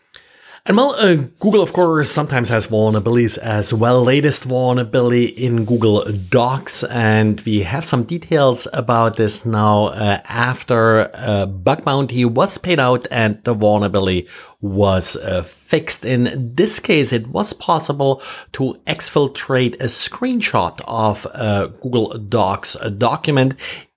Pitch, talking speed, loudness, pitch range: 120 Hz, 135 wpm, -16 LUFS, 110-135 Hz